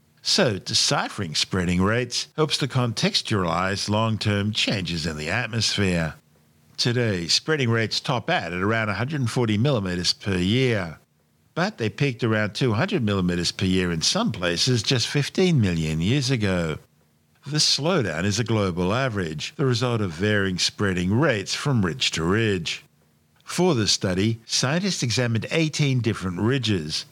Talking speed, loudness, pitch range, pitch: 140 wpm, -23 LUFS, 90-125 Hz, 105 Hz